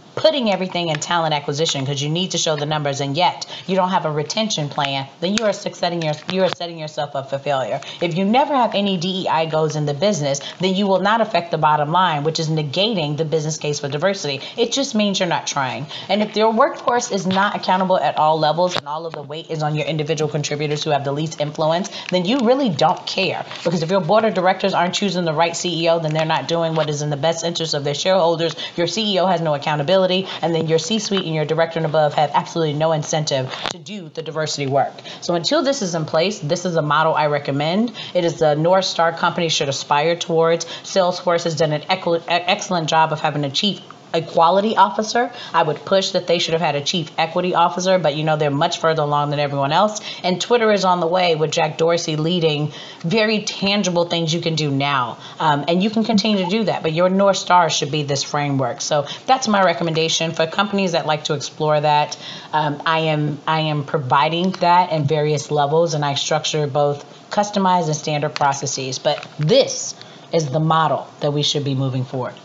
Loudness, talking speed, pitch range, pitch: -19 LUFS, 220 wpm, 150-185 Hz, 165 Hz